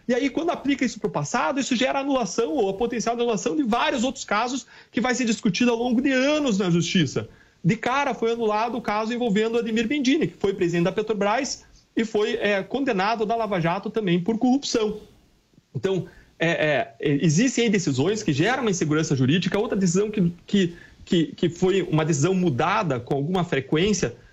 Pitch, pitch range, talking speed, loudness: 215 Hz, 175-240 Hz, 190 wpm, -23 LUFS